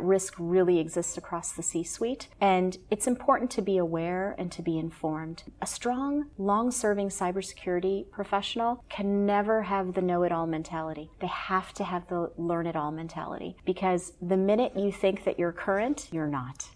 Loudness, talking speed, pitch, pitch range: -29 LUFS, 180 wpm, 185 Hz, 170-200 Hz